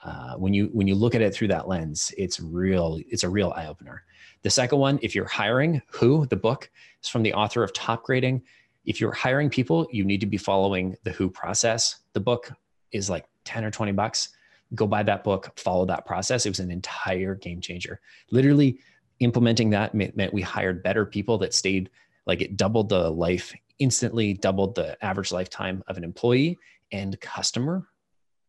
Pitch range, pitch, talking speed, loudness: 95-120 Hz, 105 Hz, 190 wpm, -25 LUFS